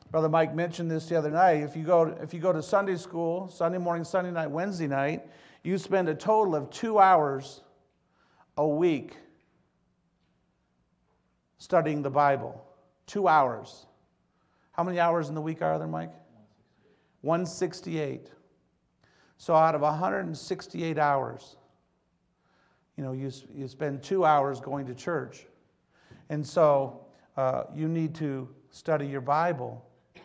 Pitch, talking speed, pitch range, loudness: 155 Hz, 140 wpm, 135-170 Hz, -28 LUFS